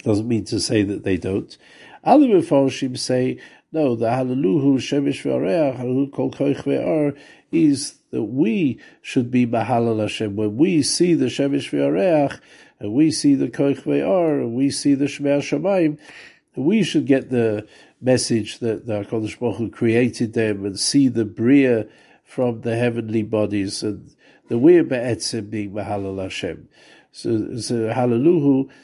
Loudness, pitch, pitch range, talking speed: -20 LUFS, 120 Hz, 110-140 Hz, 145 wpm